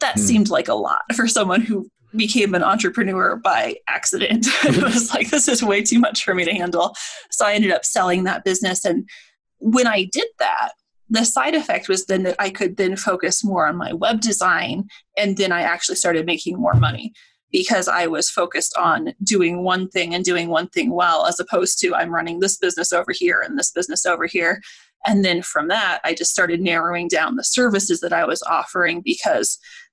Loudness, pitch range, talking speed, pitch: -19 LUFS, 180-240 Hz, 205 wpm, 200 Hz